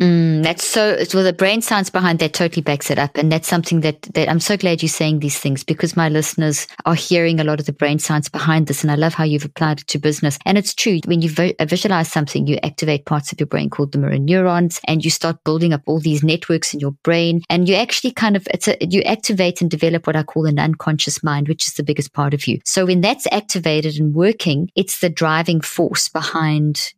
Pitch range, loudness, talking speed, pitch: 150-175 Hz, -17 LUFS, 245 wpm, 160 Hz